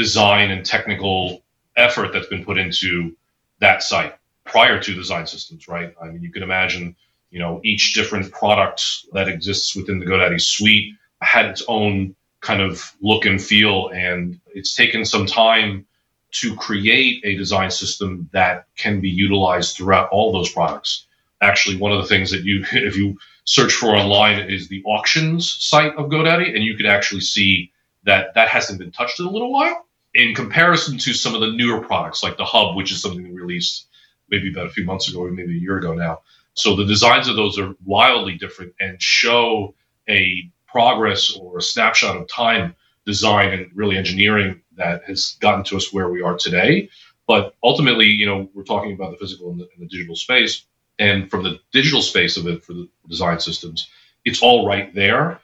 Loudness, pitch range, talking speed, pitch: -17 LUFS, 90-105 Hz, 190 wpm, 100 Hz